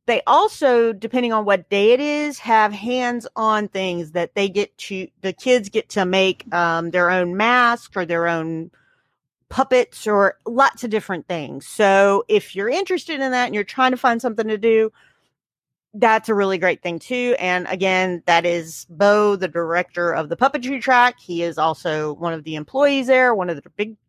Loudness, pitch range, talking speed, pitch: -19 LUFS, 175-245 Hz, 190 wpm, 205 Hz